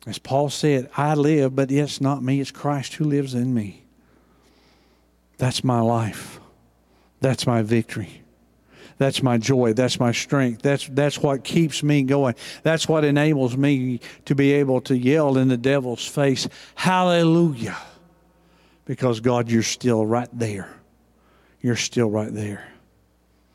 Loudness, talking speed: -21 LUFS, 145 wpm